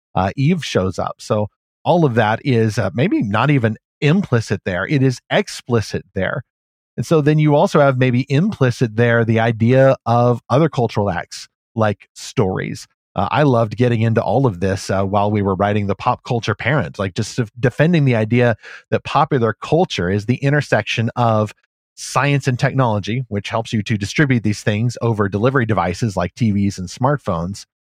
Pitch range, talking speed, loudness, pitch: 105-135 Hz, 175 wpm, -17 LUFS, 120 Hz